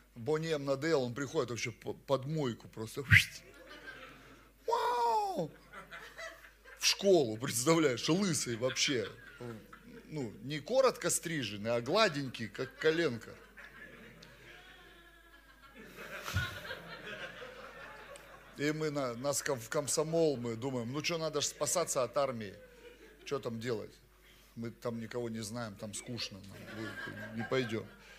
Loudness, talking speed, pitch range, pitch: -34 LUFS, 105 wpm, 120-170 Hz, 145 Hz